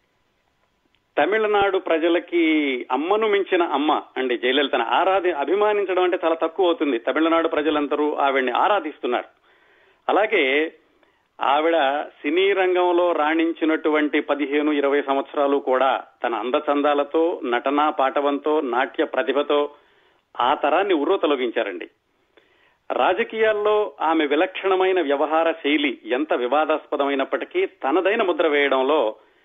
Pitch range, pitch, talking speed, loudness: 145-185 Hz, 155 Hz, 95 wpm, -21 LUFS